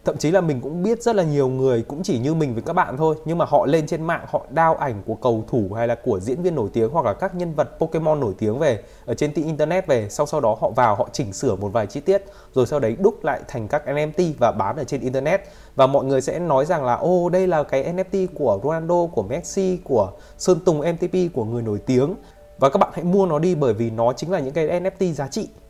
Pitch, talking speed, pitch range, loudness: 155 Hz, 275 wpm, 130-180 Hz, -21 LUFS